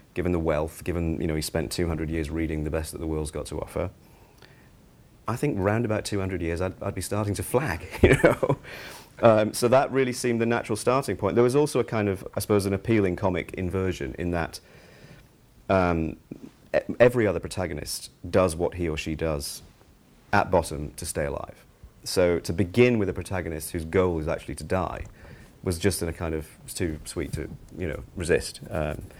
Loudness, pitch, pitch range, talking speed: -26 LUFS, 90 Hz, 80-105 Hz, 205 wpm